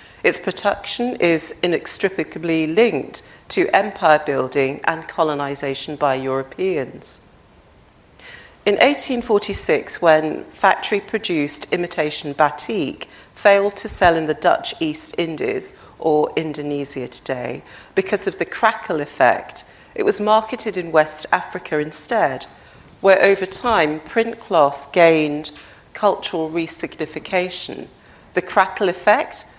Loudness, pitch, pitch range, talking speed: -19 LUFS, 175 Hz, 155-205 Hz, 105 wpm